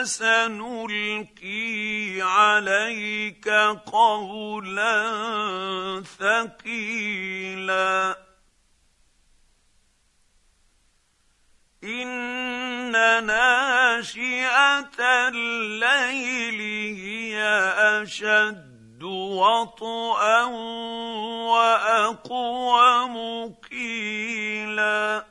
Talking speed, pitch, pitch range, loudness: 30 wpm, 215 Hz, 200-230 Hz, -22 LUFS